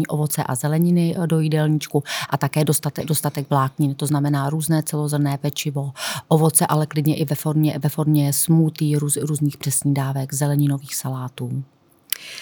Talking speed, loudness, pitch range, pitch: 140 wpm, -21 LUFS, 140-155 Hz, 150 Hz